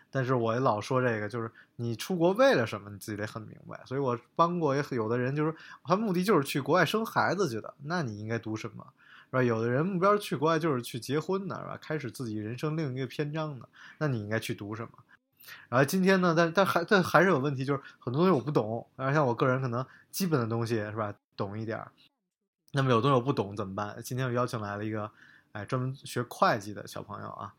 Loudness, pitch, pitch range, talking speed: -29 LUFS, 130 Hz, 115-160 Hz, 355 characters per minute